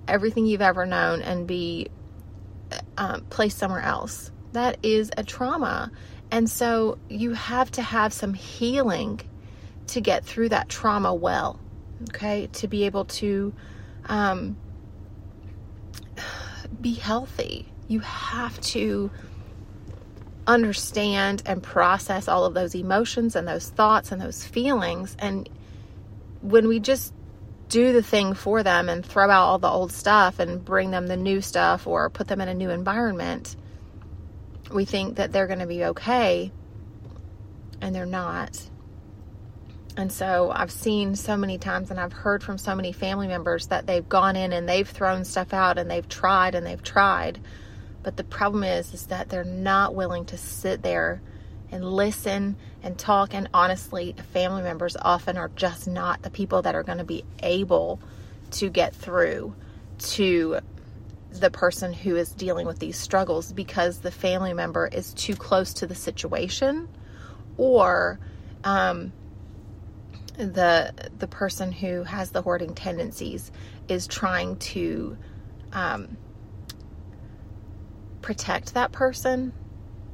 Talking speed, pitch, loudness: 145 wpm, 180 Hz, -25 LUFS